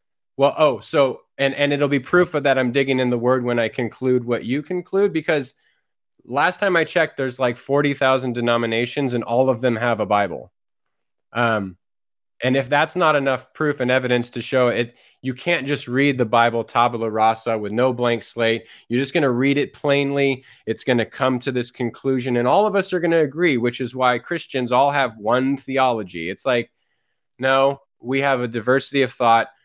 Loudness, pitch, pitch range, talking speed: -20 LUFS, 130 Hz, 120-140 Hz, 200 wpm